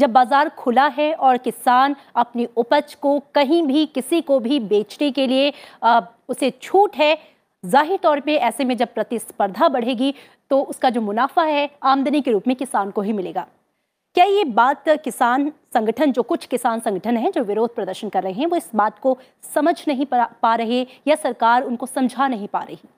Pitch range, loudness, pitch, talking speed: 235-295 Hz, -19 LUFS, 265 Hz, 190 wpm